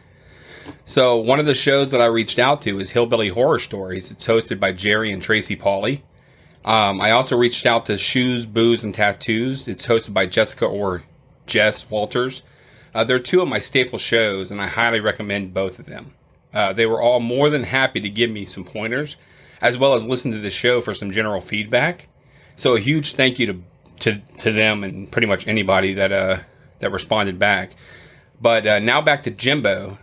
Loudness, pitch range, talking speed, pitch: -19 LUFS, 100-125 Hz, 200 wpm, 115 Hz